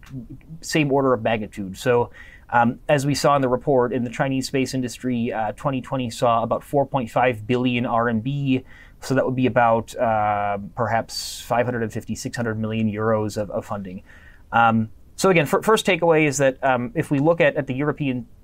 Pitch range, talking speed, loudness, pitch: 110-135 Hz, 175 wpm, -22 LUFS, 125 Hz